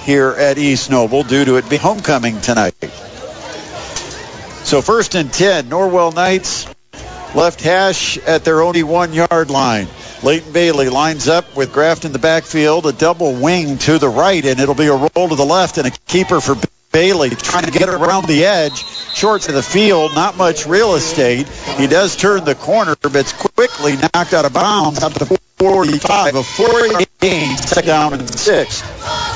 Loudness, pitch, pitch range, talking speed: -13 LUFS, 160 Hz, 140-180 Hz, 180 wpm